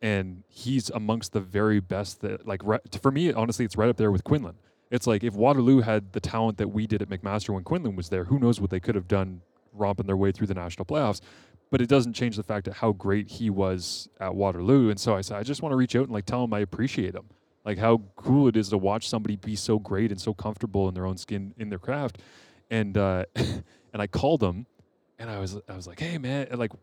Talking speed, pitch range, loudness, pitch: 255 wpm, 100-115 Hz, -27 LUFS, 105 Hz